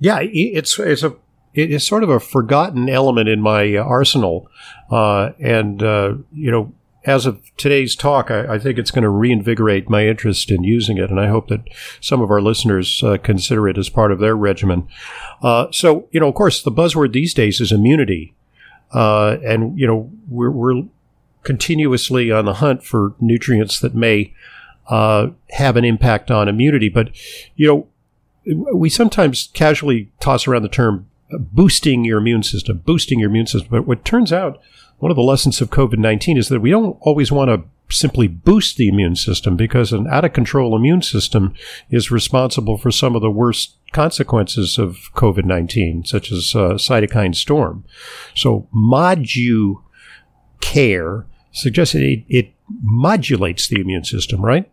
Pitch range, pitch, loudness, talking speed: 105-140 Hz, 120 Hz, -16 LUFS, 175 wpm